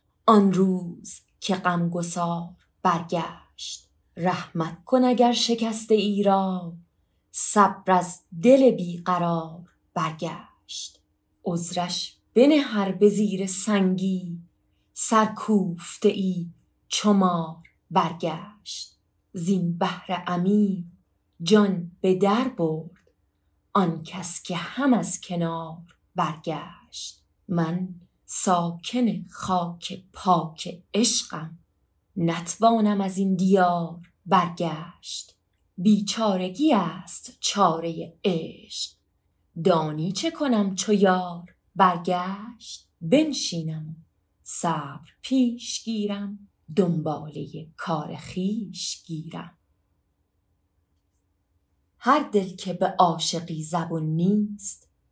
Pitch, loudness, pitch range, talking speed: 180 Hz, -24 LUFS, 165-200 Hz, 85 wpm